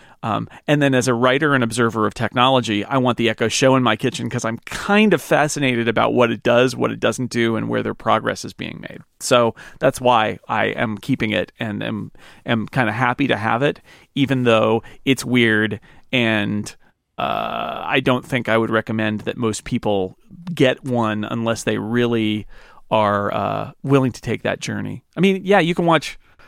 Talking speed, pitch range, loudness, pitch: 195 wpm, 110-135 Hz, -19 LUFS, 120 Hz